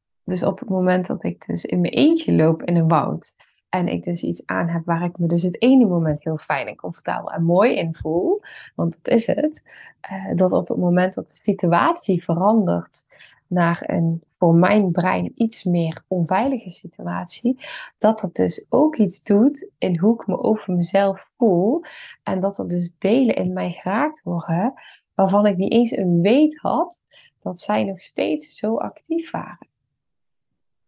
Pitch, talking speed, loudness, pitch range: 185 Hz, 180 wpm, -20 LUFS, 170-225 Hz